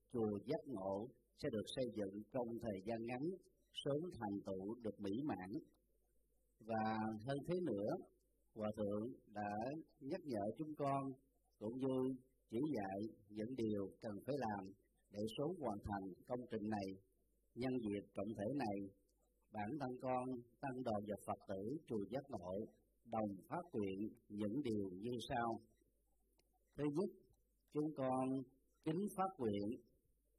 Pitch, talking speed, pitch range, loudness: 115 Hz, 145 wpm, 105-130 Hz, -46 LUFS